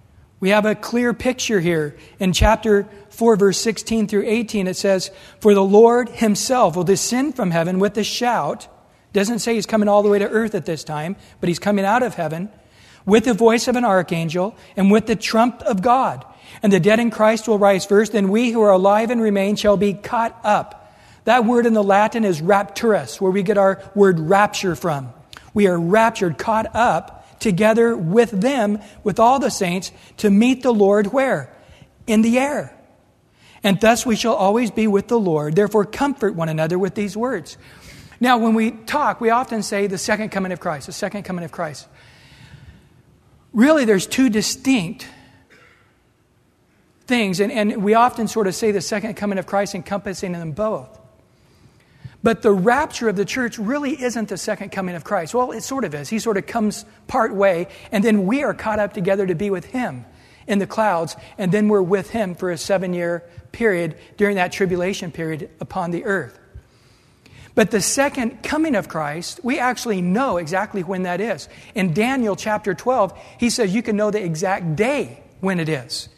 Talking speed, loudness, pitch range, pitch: 195 wpm, -19 LUFS, 190-225 Hz, 205 Hz